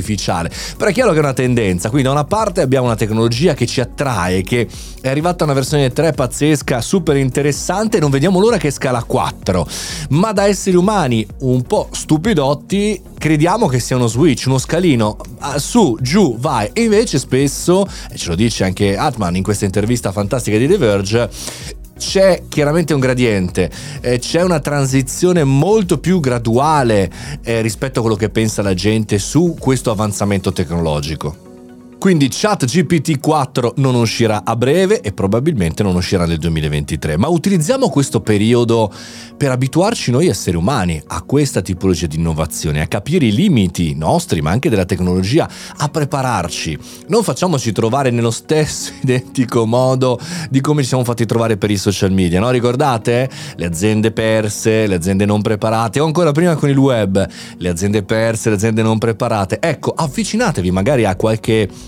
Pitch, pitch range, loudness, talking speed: 125 Hz, 105-150 Hz, -15 LUFS, 165 wpm